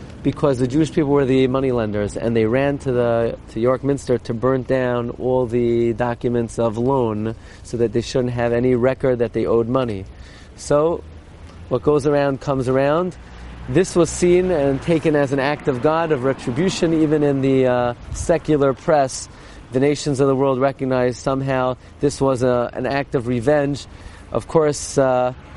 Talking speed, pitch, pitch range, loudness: 180 wpm, 130 Hz, 120-145 Hz, -19 LUFS